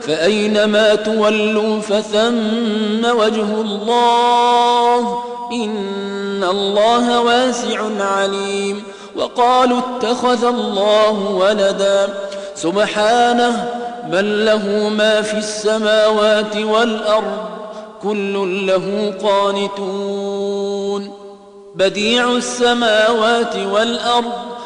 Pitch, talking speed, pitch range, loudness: 215 Hz, 65 wpm, 200-235 Hz, -16 LUFS